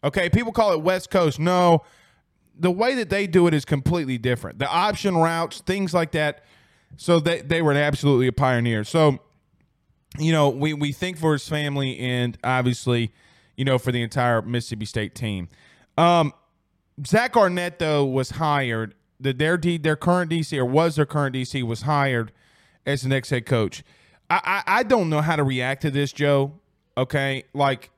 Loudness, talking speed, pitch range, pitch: -22 LUFS, 180 wpm, 125-170 Hz, 145 Hz